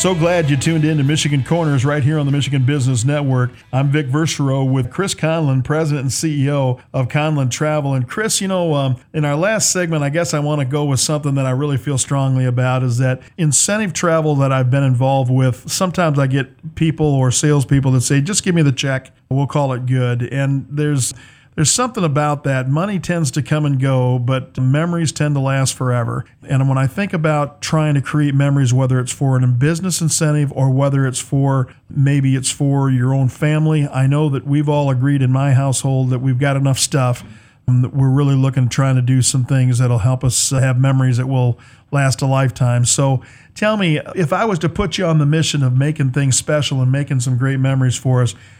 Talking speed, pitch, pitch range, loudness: 215 wpm, 140 Hz, 130-150 Hz, -16 LUFS